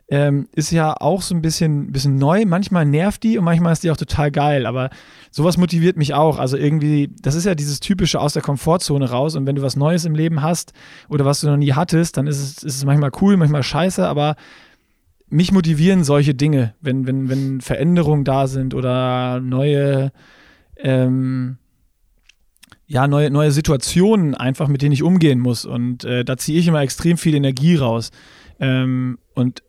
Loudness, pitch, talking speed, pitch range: -17 LUFS, 145 Hz, 190 wpm, 135-165 Hz